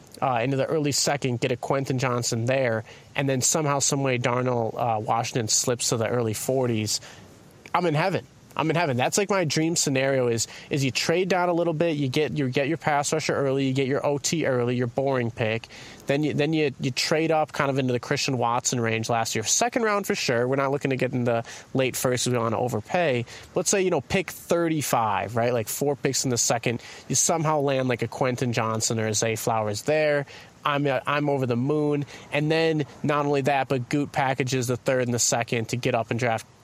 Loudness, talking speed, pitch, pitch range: -24 LUFS, 230 wpm, 135 Hz, 120-145 Hz